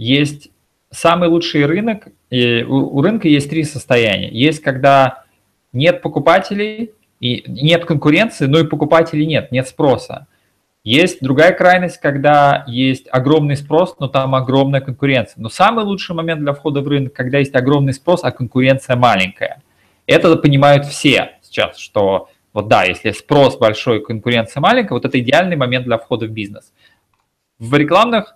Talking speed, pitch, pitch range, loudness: 150 wpm, 140 Hz, 130-165 Hz, -14 LUFS